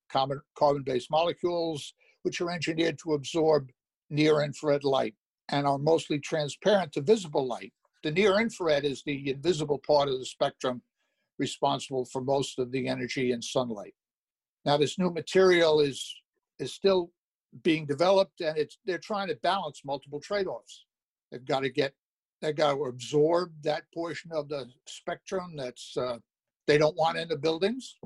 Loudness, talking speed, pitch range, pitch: -29 LUFS, 150 wpm, 140-170 Hz, 150 Hz